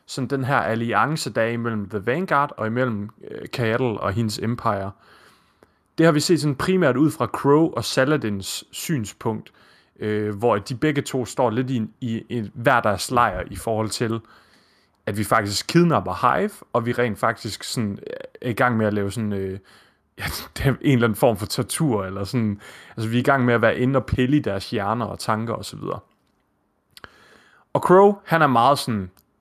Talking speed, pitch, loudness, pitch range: 190 wpm, 115 Hz, -22 LUFS, 105-135 Hz